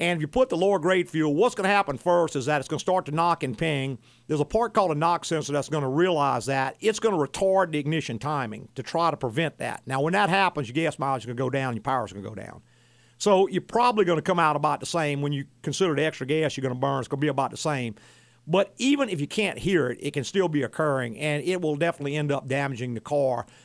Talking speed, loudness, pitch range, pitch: 290 wpm, -25 LUFS, 135-175 Hz, 150 Hz